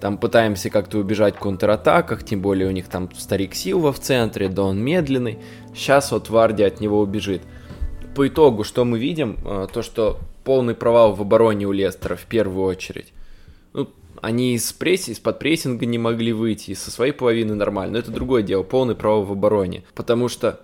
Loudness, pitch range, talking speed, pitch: -20 LUFS, 95-115 Hz, 185 wpm, 105 Hz